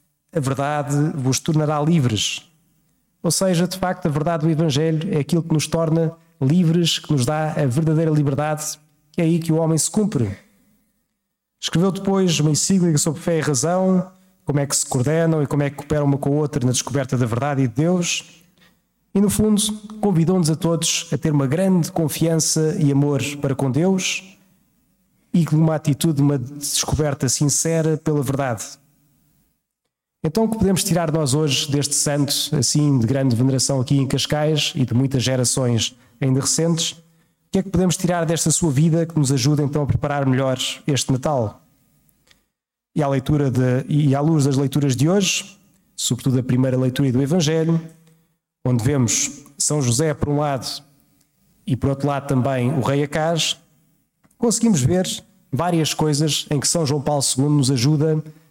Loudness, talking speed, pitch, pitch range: -19 LUFS, 175 wpm, 155 Hz, 140-170 Hz